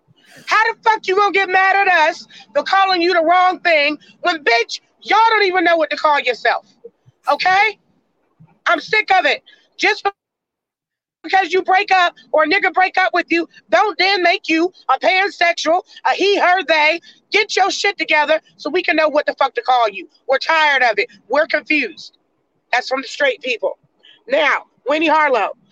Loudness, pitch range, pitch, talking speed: -15 LUFS, 305-390 Hz, 345 Hz, 185 wpm